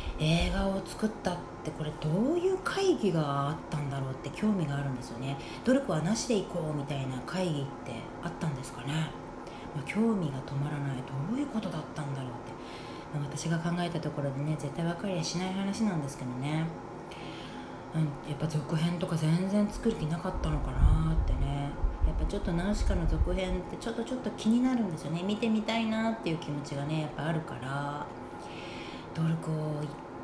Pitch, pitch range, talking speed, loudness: 155 Hz, 140-190 Hz, 395 characters per minute, -32 LUFS